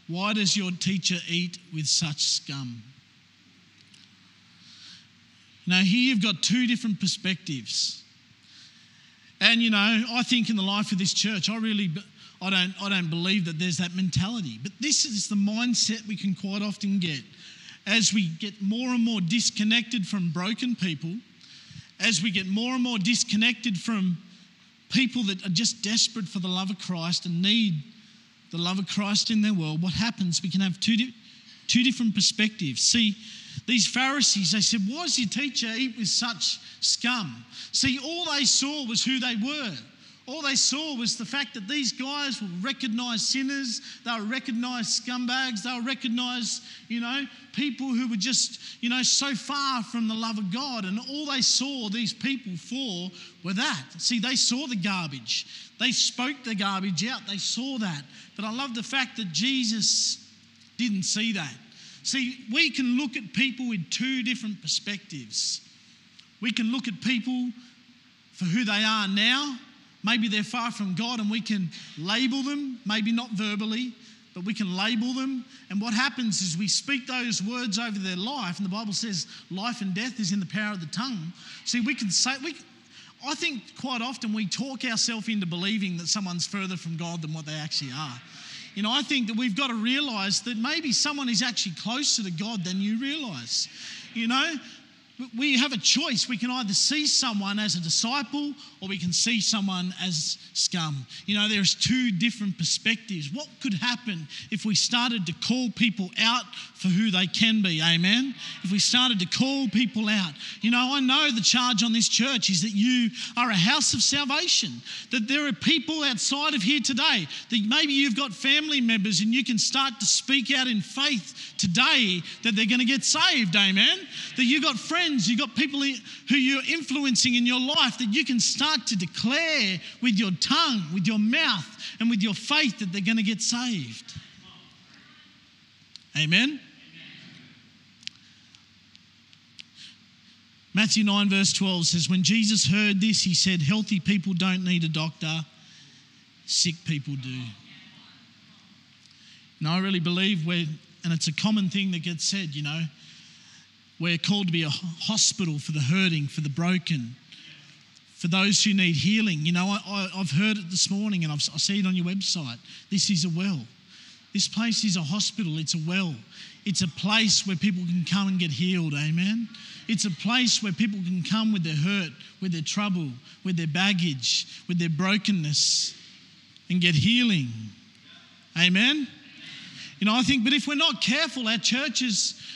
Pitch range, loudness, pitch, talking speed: 185-245 Hz, -25 LUFS, 215 Hz, 180 wpm